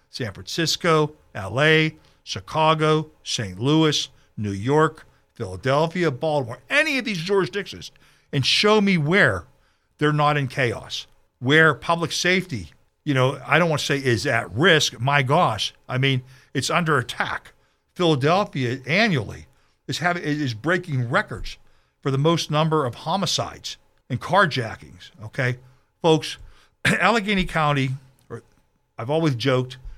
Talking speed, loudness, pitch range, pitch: 130 wpm, -21 LUFS, 130-160 Hz, 145 Hz